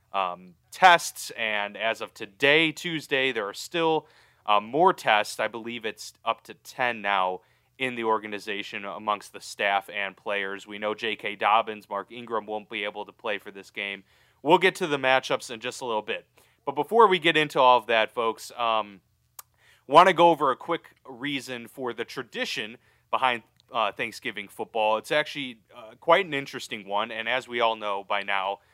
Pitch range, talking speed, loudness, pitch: 105-130 Hz, 190 wpm, -25 LUFS, 115 Hz